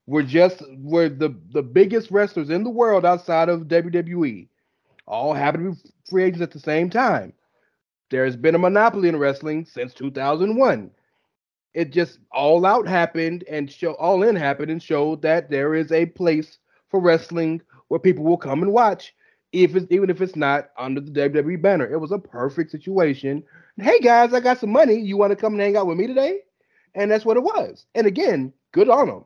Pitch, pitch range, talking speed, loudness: 170 Hz, 155-195 Hz, 200 wpm, -20 LUFS